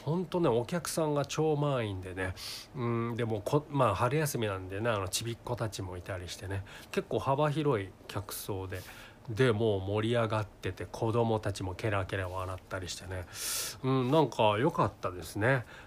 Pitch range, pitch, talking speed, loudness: 100-130 Hz, 110 Hz, 335 characters per minute, -32 LUFS